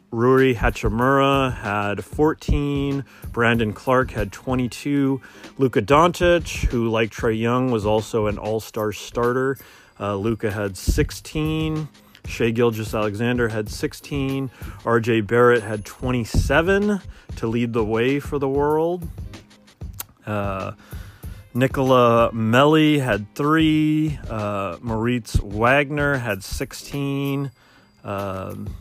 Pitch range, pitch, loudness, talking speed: 105-135 Hz, 120 Hz, -21 LUFS, 105 wpm